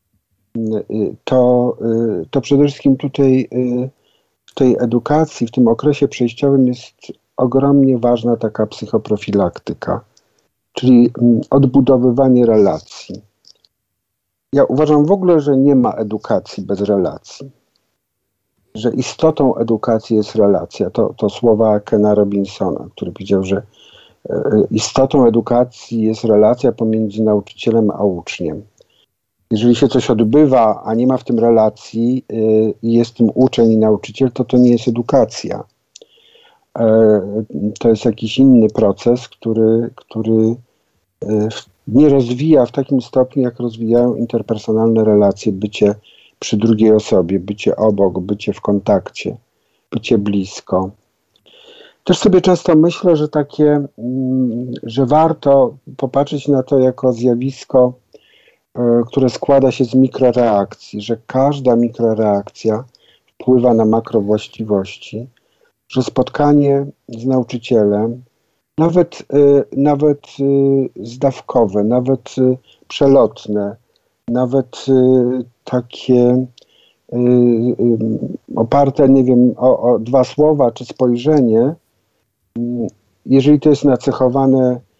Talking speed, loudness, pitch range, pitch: 105 wpm, -14 LUFS, 110-135 Hz, 120 Hz